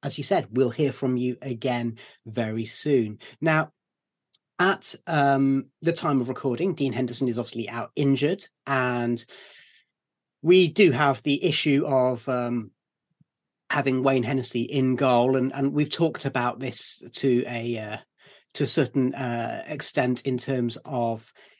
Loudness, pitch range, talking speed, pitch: -25 LUFS, 120-145 Hz, 145 wpm, 130 Hz